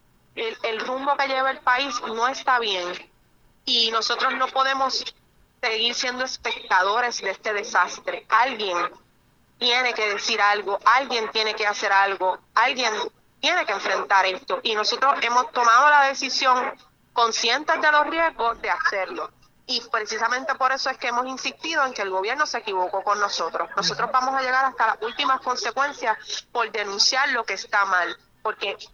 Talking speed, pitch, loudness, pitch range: 160 wpm, 245 Hz, -22 LUFS, 215-265 Hz